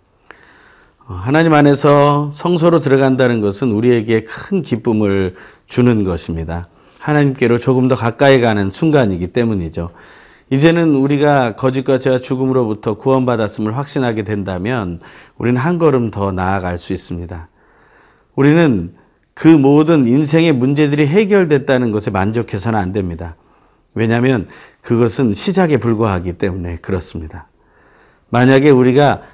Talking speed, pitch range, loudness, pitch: 315 characters per minute, 100-140 Hz, -14 LUFS, 120 Hz